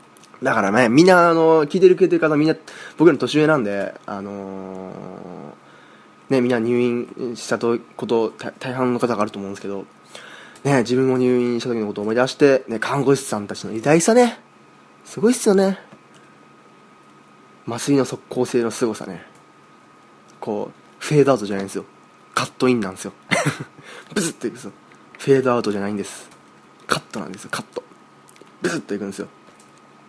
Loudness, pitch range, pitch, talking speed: -19 LUFS, 105-140 Hz, 125 Hz, 355 characters per minute